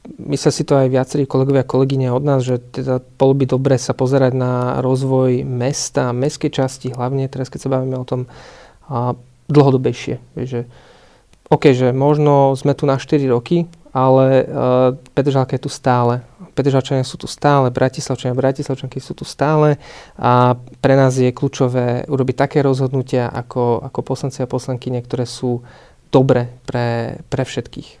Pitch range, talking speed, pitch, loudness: 125-140 Hz, 155 wpm, 130 Hz, -17 LUFS